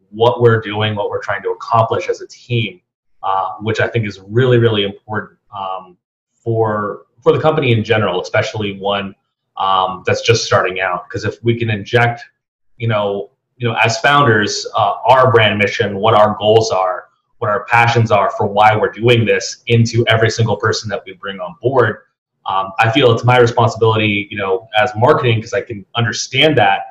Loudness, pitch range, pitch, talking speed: -15 LUFS, 105-120 Hz, 115 Hz, 190 wpm